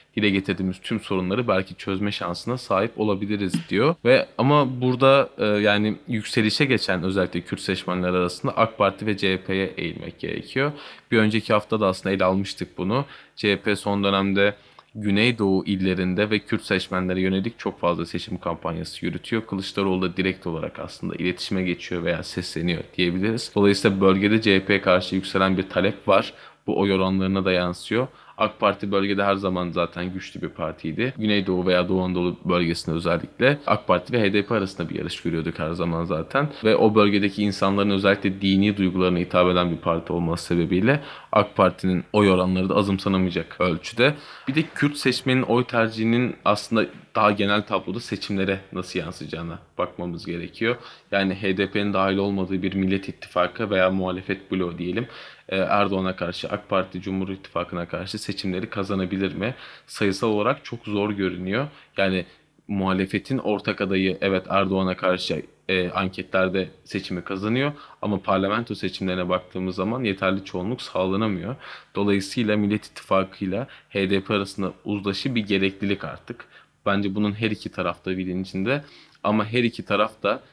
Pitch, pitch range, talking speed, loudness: 95 Hz, 90-105 Hz, 150 wpm, -23 LUFS